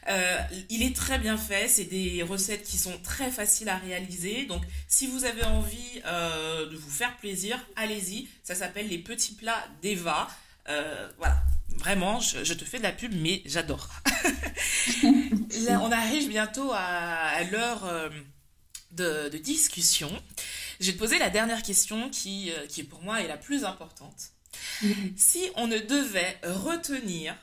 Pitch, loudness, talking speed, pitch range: 200 Hz, -28 LUFS, 160 wpm, 170-230 Hz